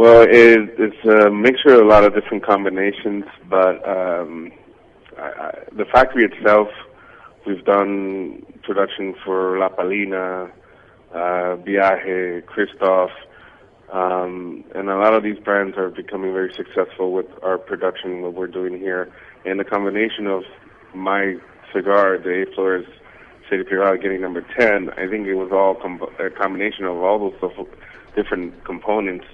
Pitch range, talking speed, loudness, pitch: 90-100 Hz, 145 wpm, -18 LUFS, 95 Hz